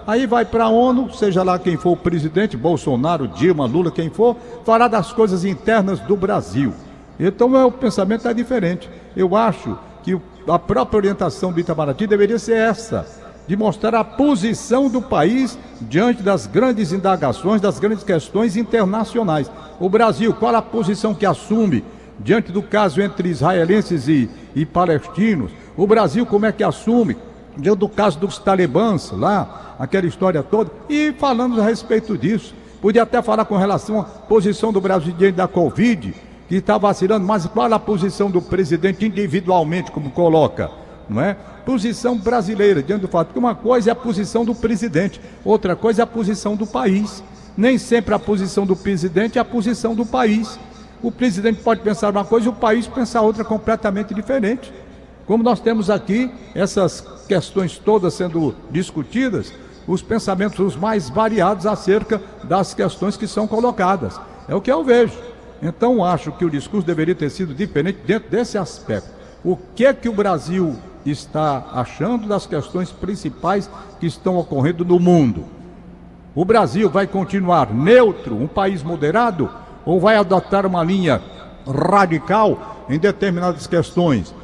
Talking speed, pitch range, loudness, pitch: 160 wpm, 180-225 Hz, -18 LUFS, 205 Hz